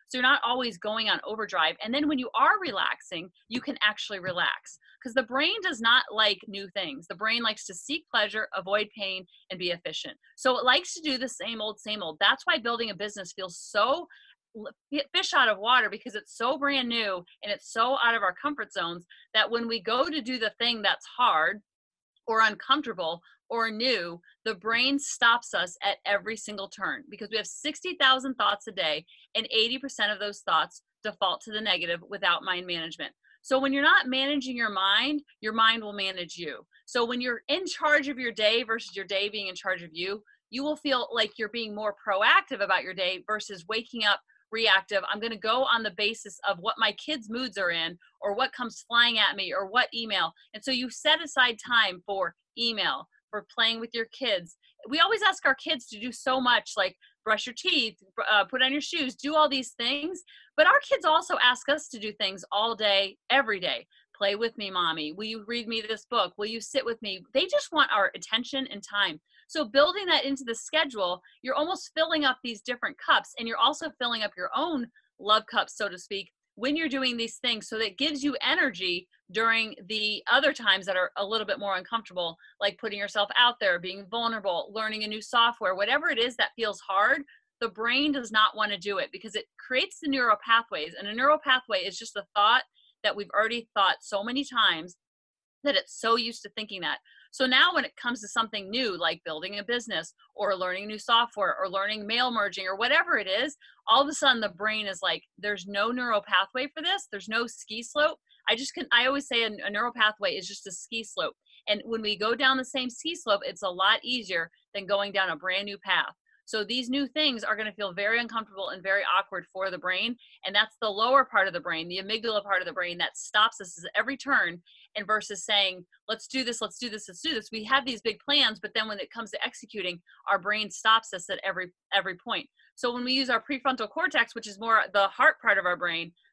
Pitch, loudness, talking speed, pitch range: 225 Hz, -27 LUFS, 225 wpm, 200-265 Hz